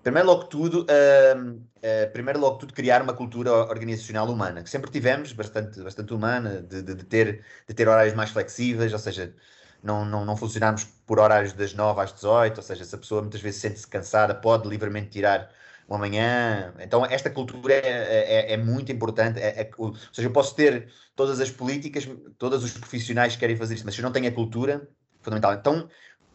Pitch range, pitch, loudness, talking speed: 105-130 Hz, 115 Hz, -24 LUFS, 200 wpm